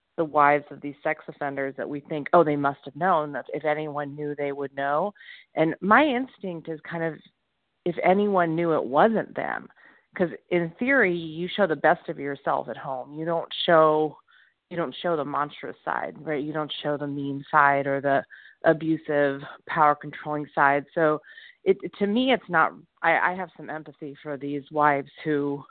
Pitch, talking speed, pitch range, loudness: 155 Hz, 190 wpm, 145-170 Hz, -25 LUFS